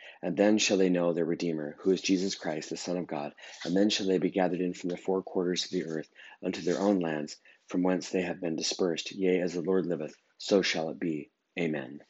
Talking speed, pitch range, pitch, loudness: 245 wpm, 85-95 Hz, 90 Hz, -30 LUFS